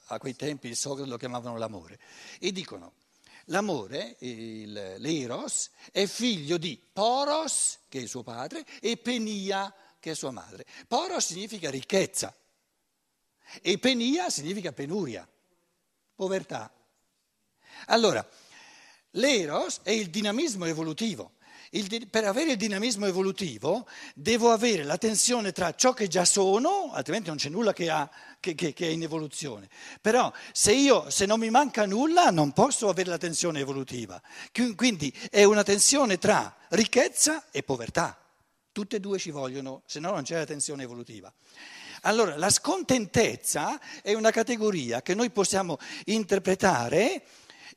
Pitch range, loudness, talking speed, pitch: 155-230 Hz, -27 LUFS, 140 wpm, 195 Hz